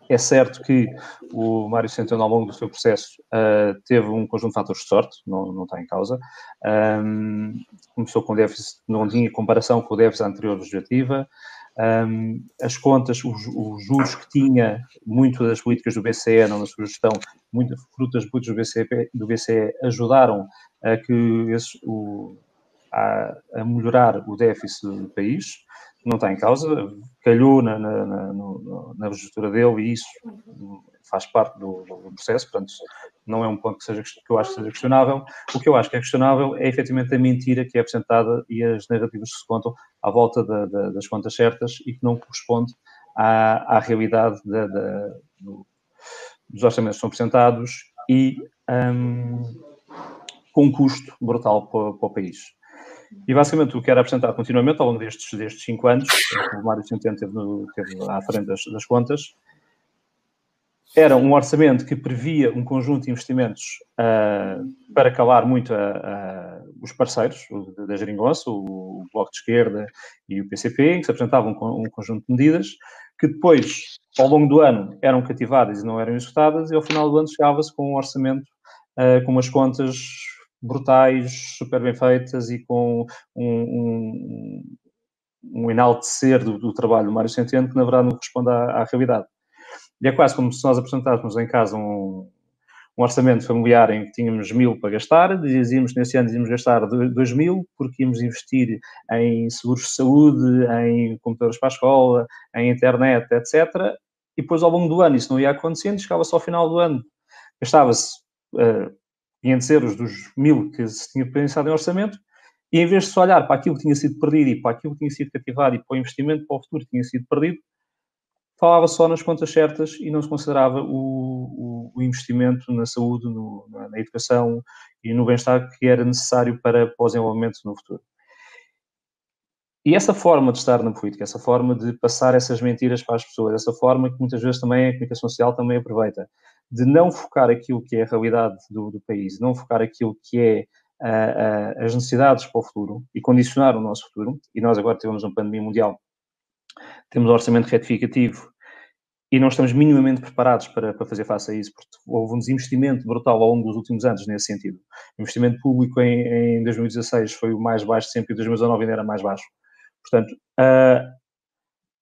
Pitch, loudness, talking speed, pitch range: 120 Hz, -20 LUFS, 185 wpm, 115-130 Hz